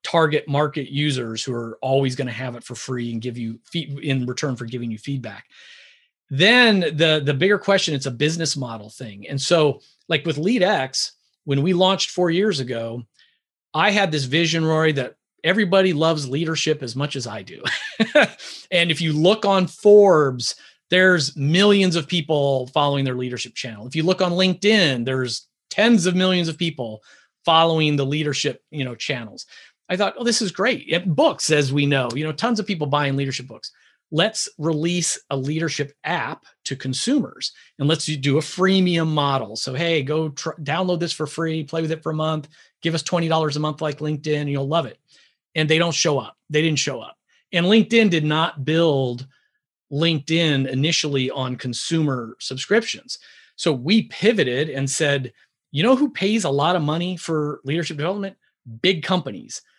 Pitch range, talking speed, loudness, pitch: 135-175 Hz, 185 wpm, -20 LUFS, 155 Hz